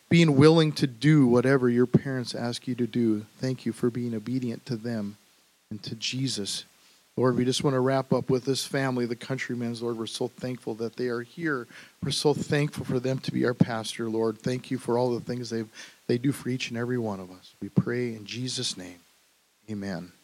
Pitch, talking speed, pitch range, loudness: 125 Hz, 215 wpm, 115-130 Hz, -27 LUFS